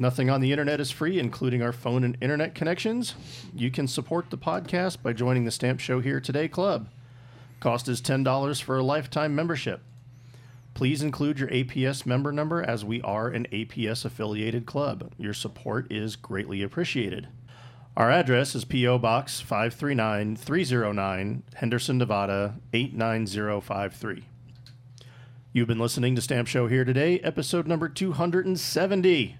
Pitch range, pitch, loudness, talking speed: 120-145 Hz, 125 Hz, -27 LUFS, 145 wpm